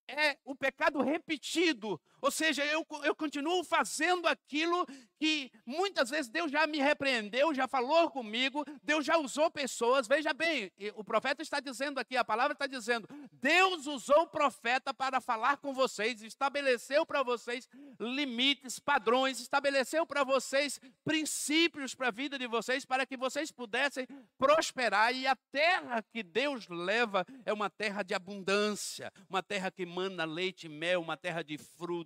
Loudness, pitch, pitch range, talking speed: -32 LUFS, 265 Hz, 230-295 Hz, 160 wpm